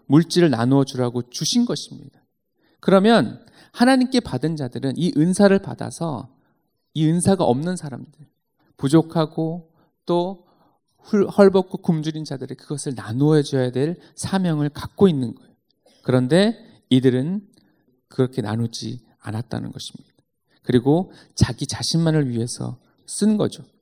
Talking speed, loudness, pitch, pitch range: 280 characters per minute, -20 LUFS, 155 Hz, 130-175 Hz